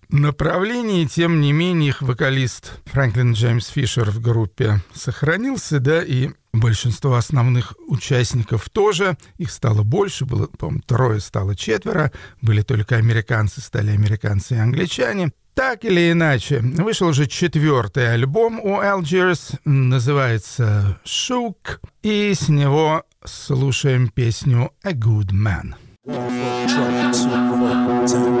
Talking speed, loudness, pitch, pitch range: 110 wpm, -19 LUFS, 130 Hz, 115-155 Hz